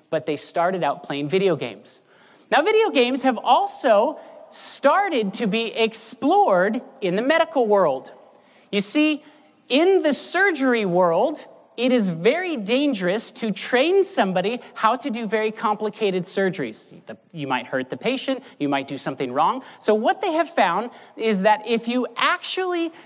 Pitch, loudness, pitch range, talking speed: 235 Hz, -21 LUFS, 195-300 Hz, 155 wpm